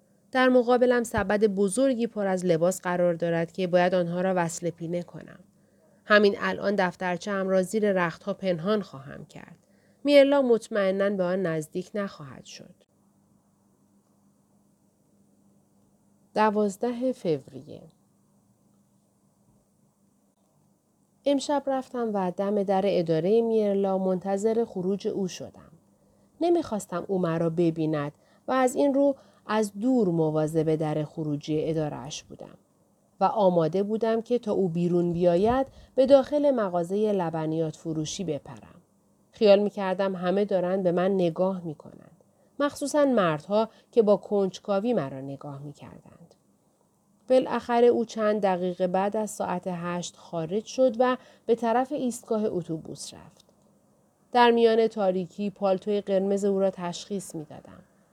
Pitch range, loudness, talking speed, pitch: 175-220 Hz, -26 LUFS, 125 wpm, 195 Hz